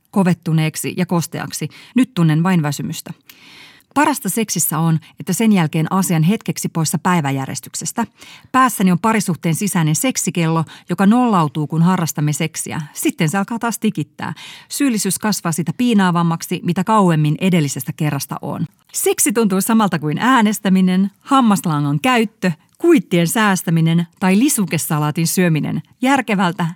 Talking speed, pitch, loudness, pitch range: 120 wpm, 180 Hz, -17 LUFS, 160-210 Hz